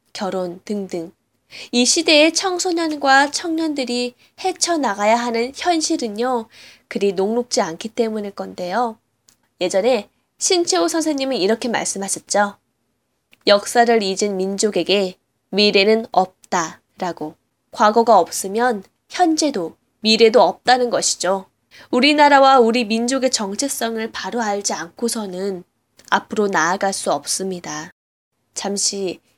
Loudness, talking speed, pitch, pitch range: -18 LUFS, 260 characters per minute, 220 Hz, 190-255 Hz